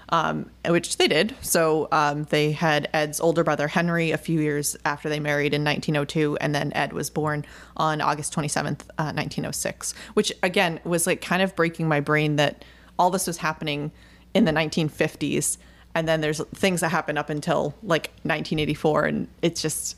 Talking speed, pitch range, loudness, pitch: 180 wpm, 150-170 Hz, -24 LUFS, 155 Hz